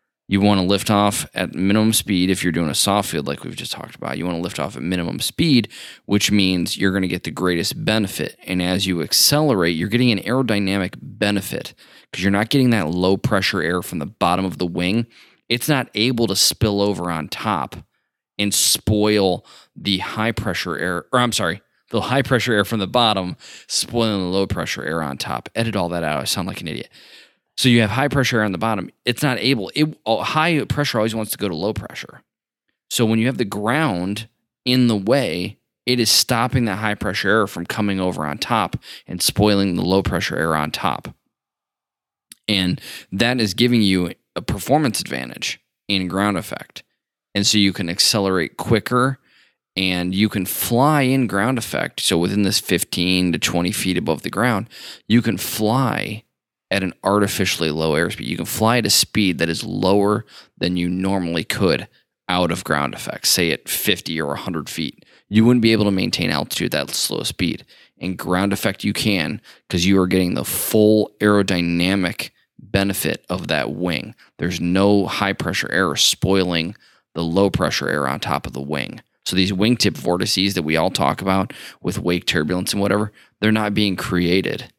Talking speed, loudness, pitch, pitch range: 195 wpm, -19 LUFS, 100 Hz, 90-110 Hz